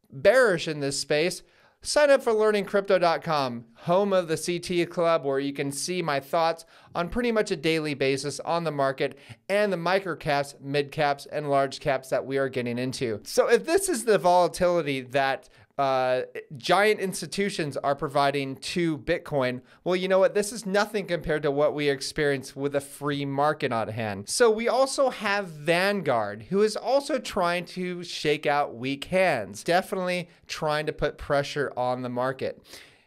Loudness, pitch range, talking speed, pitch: -26 LUFS, 140-185 Hz, 175 wpm, 160 Hz